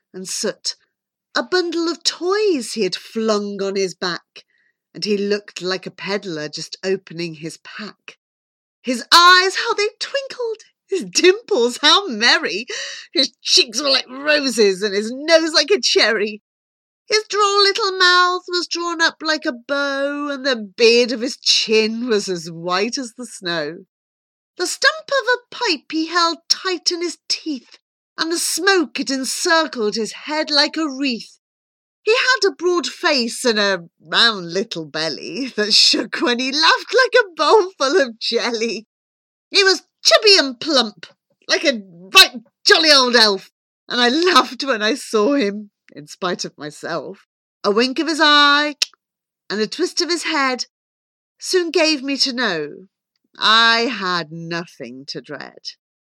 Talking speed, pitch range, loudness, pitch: 160 wpm, 205-340 Hz, -17 LUFS, 270 Hz